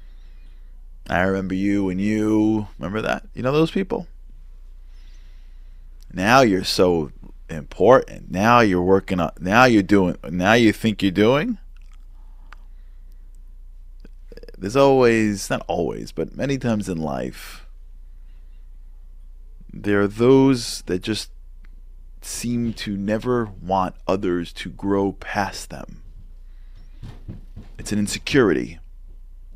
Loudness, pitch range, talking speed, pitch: -20 LUFS, 60-105 Hz, 110 wpm, 85 Hz